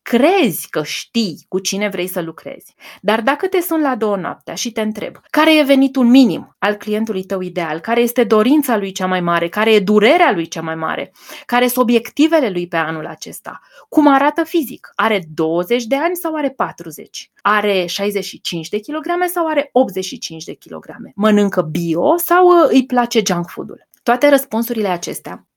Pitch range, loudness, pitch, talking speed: 185-275 Hz, -16 LUFS, 220 Hz, 180 wpm